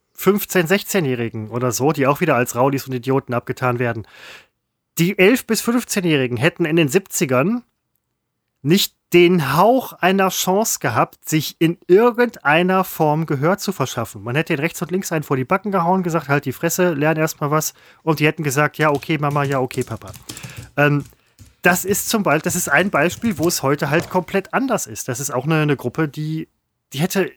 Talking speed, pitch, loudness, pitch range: 190 wpm, 160 Hz, -18 LUFS, 135-185 Hz